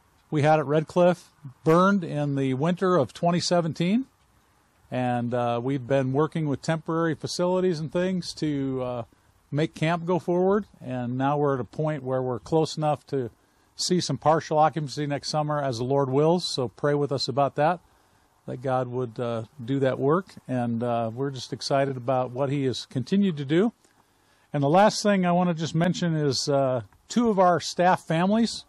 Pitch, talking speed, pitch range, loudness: 145 Hz, 185 wpm, 130-170 Hz, -25 LUFS